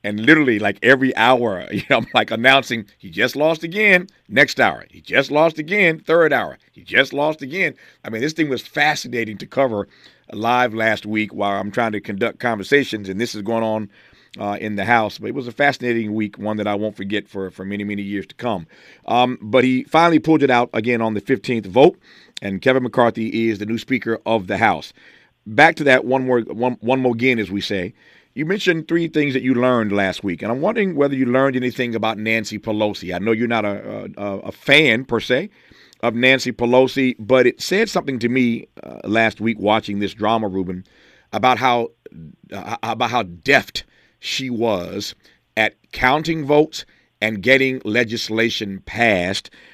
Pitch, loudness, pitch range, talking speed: 115 Hz, -18 LUFS, 105-130 Hz, 200 wpm